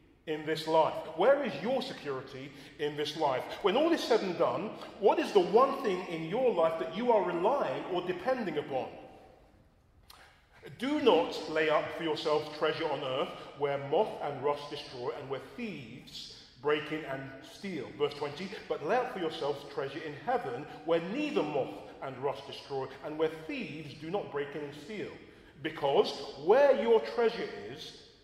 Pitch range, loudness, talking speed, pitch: 145-220 Hz, -32 LUFS, 175 wpm, 160 Hz